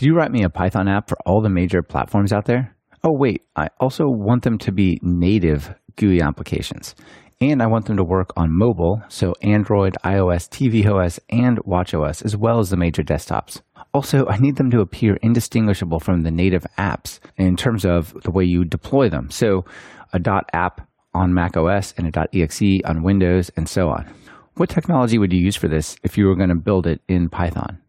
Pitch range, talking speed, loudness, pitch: 90-110 Hz, 205 wpm, -19 LUFS, 95 Hz